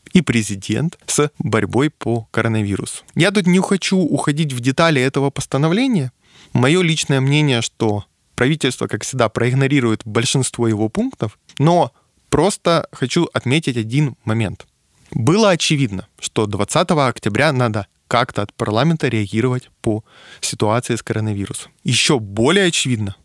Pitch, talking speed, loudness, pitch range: 130 Hz, 125 wpm, -18 LUFS, 110-155 Hz